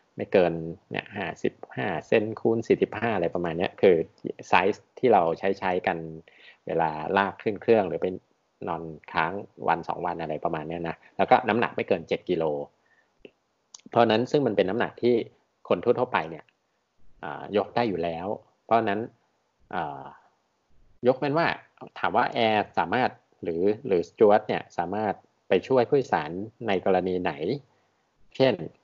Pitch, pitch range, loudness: 90 Hz, 85-115 Hz, -26 LUFS